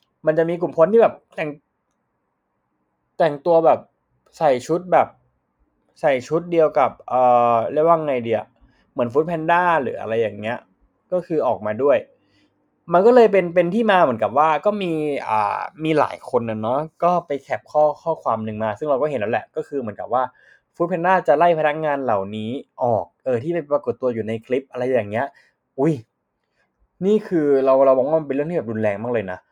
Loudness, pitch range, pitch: -20 LUFS, 125-170 Hz, 155 Hz